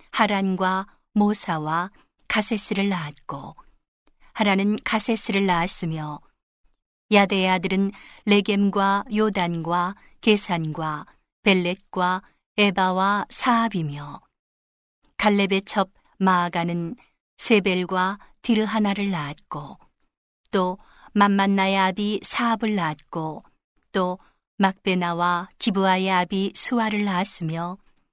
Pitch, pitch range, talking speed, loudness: 195 Hz, 175-205 Hz, 210 characters per minute, -23 LUFS